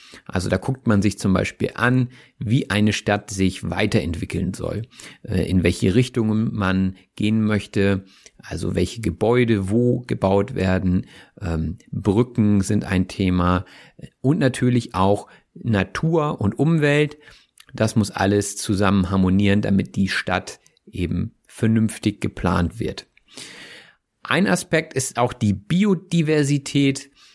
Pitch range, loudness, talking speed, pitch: 95-125 Hz, -21 LUFS, 120 wpm, 105 Hz